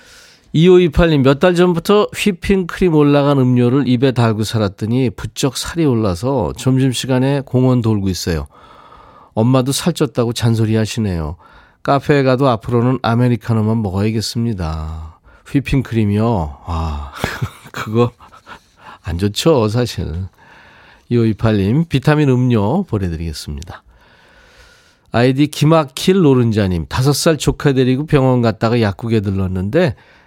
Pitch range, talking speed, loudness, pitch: 105-145 Hz, 270 characters per minute, -15 LUFS, 120 Hz